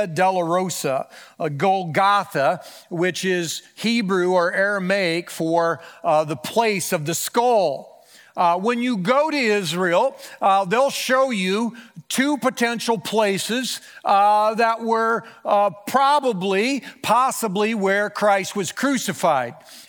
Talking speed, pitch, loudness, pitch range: 110 wpm, 205 Hz, -20 LUFS, 185-235 Hz